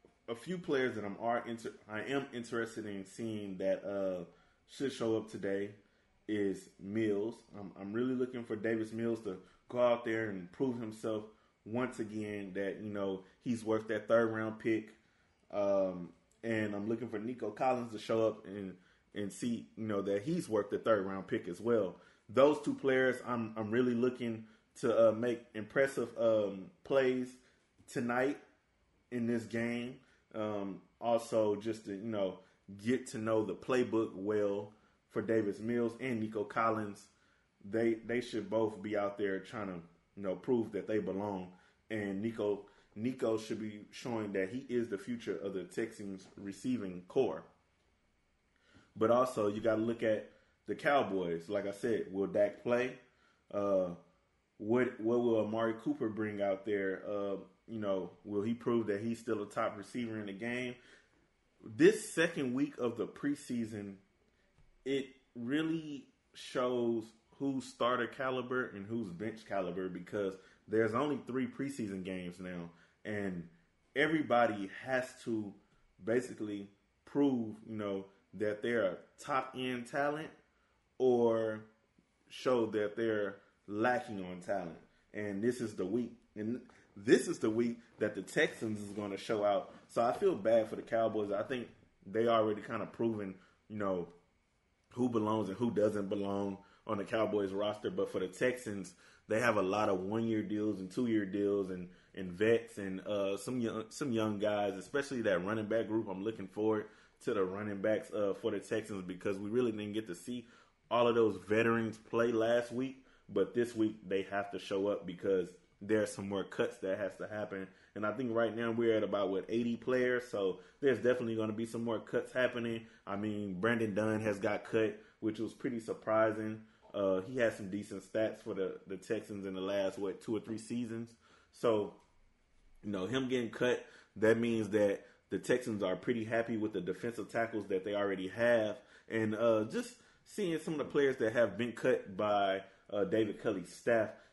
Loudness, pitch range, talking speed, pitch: -36 LUFS, 100-120 Hz, 175 wpm, 110 Hz